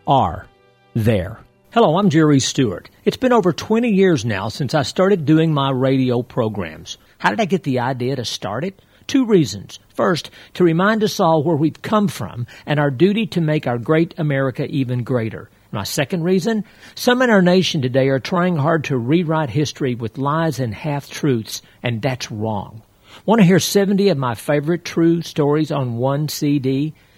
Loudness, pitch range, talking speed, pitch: -18 LUFS, 125-180 Hz, 185 wpm, 150 Hz